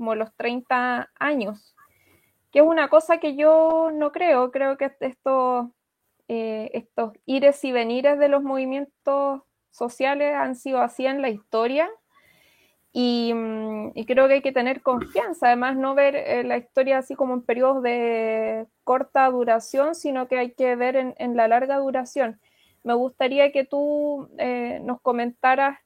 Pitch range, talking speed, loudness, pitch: 240-280 Hz, 160 wpm, -22 LUFS, 260 Hz